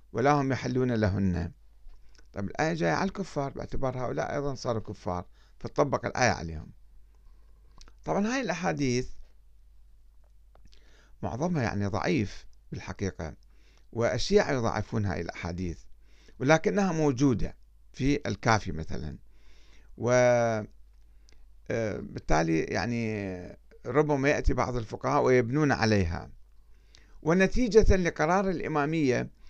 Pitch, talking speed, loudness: 110 Hz, 90 wpm, -28 LUFS